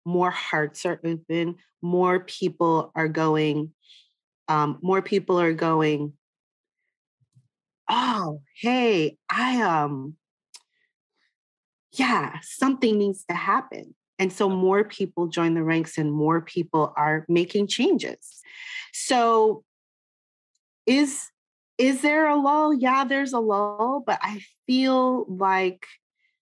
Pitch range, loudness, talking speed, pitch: 165-255 Hz, -23 LUFS, 110 wpm, 190 Hz